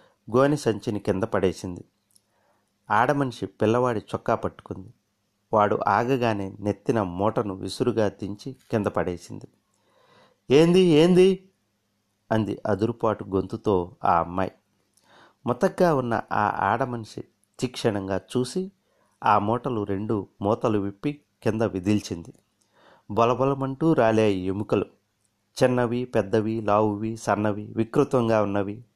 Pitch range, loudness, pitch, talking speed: 100-125 Hz, -24 LUFS, 110 Hz, 95 wpm